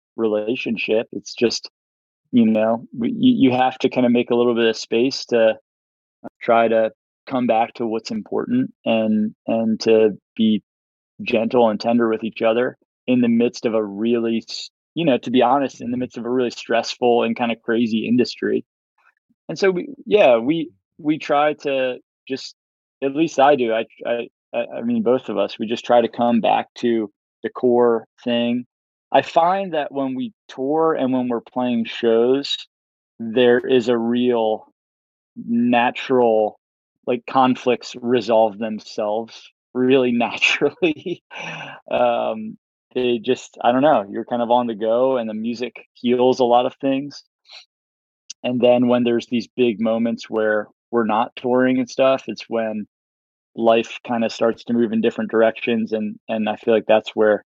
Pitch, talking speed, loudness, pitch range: 120 Hz, 170 wpm, -20 LUFS, 110-125 Hz